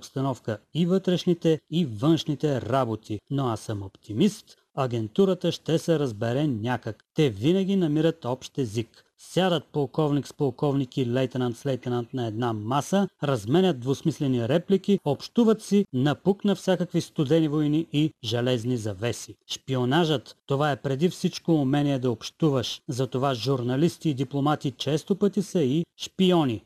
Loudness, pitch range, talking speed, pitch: -26 LUFS, 125-170 Hz, 130 wpm, 145 Hz